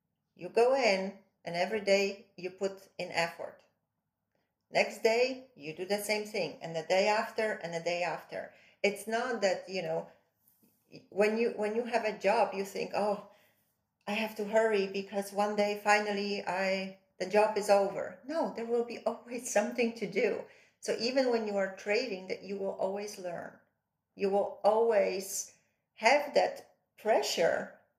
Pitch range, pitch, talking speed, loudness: 195-220 Hz, 205 Hz, 165 wpm, -32 LUFS